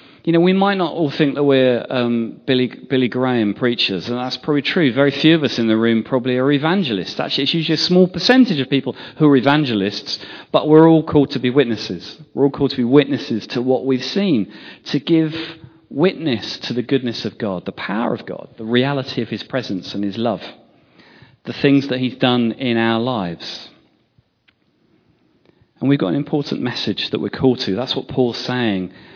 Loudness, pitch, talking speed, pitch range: -18 LUFS, 130 Hz, 200 wpm, 115-145 Hz